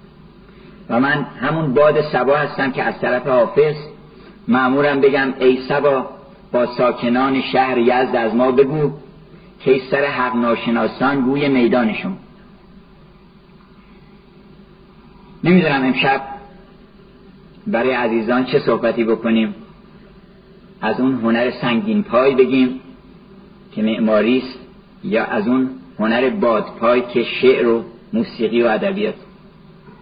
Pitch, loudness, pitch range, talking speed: 185 Hz, -17 LUFS, 130-195 Hz, 110 wpm